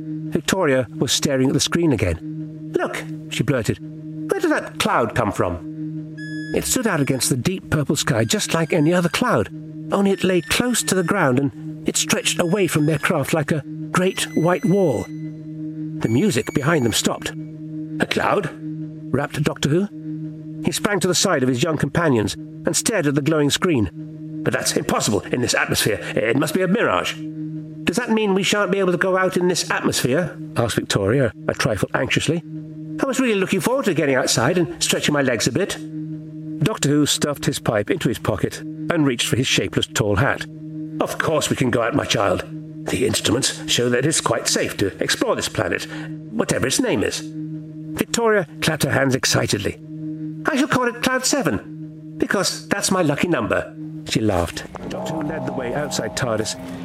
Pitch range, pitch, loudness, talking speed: 155-175 Hz, 155 Hz, -20 LUFS, 190 wpm